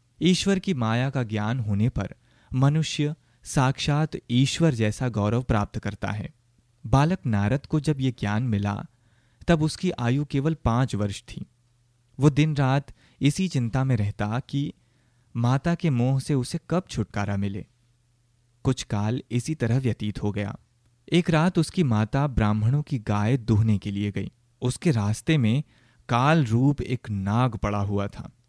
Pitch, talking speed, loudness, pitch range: 120 Hz, 155 wpm, -25 LUFS, 110-145 Hz